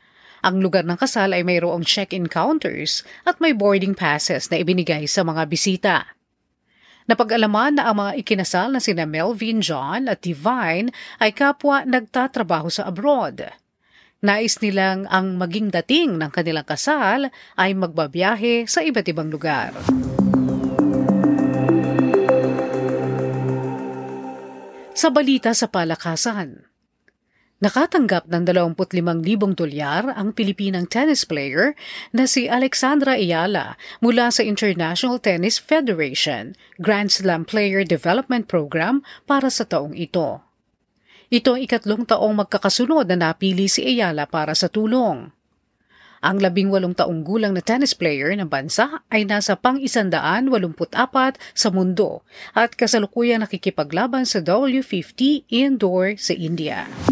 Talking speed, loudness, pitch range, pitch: 120 wpm, -20 LUFS, 170-240 Hz, 200 Hz